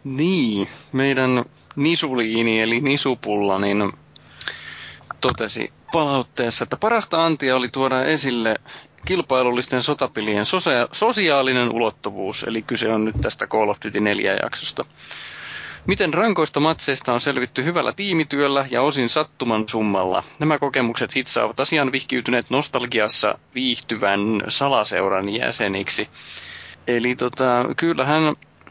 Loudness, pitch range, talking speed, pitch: -20 LUFS, 115-145 Hz, 105 wpm, 130 Hz